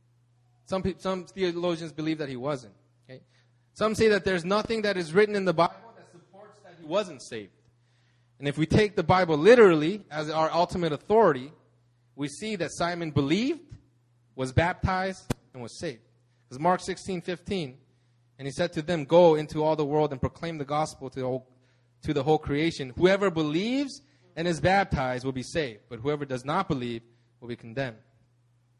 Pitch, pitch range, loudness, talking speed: 150 Hz, 125-180 Hz, -26 LUFS, 180 wpm